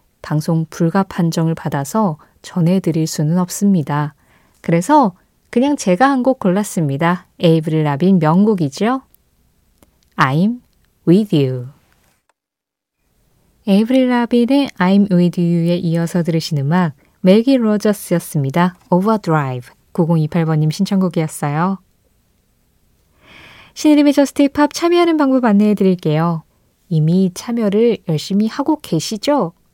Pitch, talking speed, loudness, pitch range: 180 Hz, 280 characters per minute, -16 LUFS, 160-220 Hz